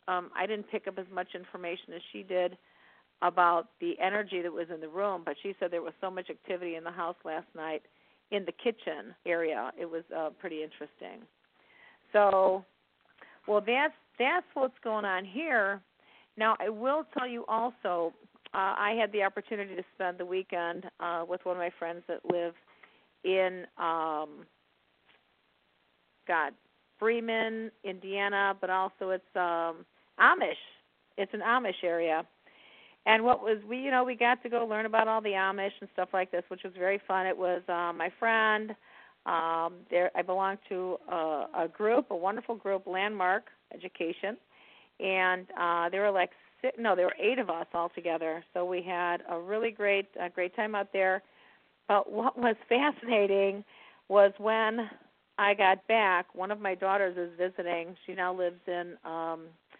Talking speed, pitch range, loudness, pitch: 175 wpm, 175-215 Hz, -31 LUFS, 190 Hz